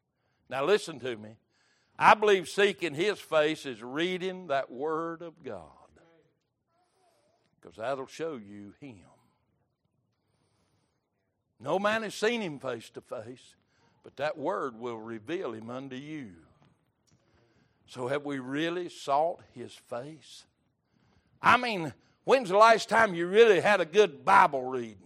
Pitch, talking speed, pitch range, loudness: 140 Hz, 135 wpm, 120-175 Hz, -27 LUFS